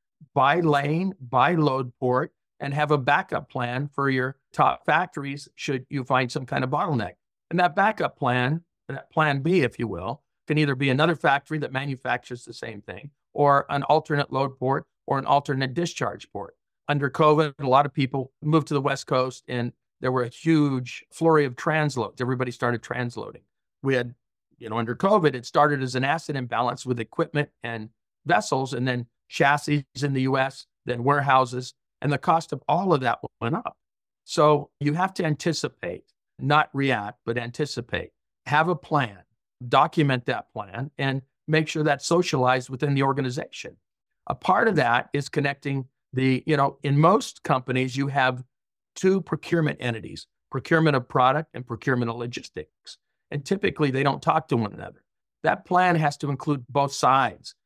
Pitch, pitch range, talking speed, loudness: 140 Hz, 125-150 Hz, 175 wpm, -24 LUFS